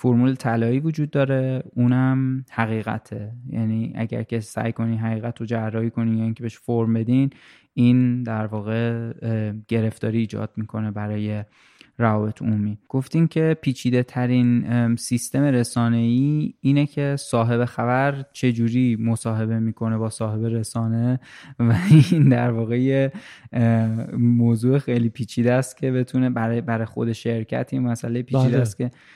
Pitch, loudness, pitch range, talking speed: 120 Hz, -22 LUFS, 115-130 Hz, 135 wpm